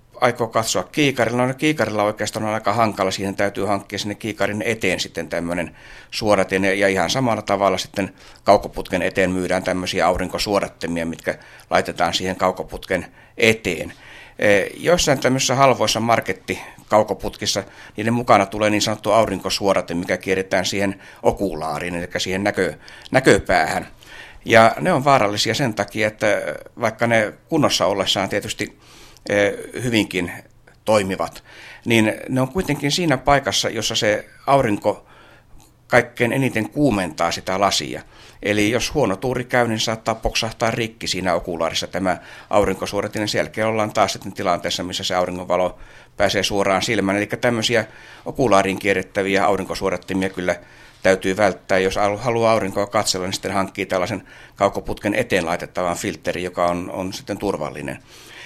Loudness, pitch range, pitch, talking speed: -20 LUFS, 95-115 Hz, 100 Hz, 135 wpm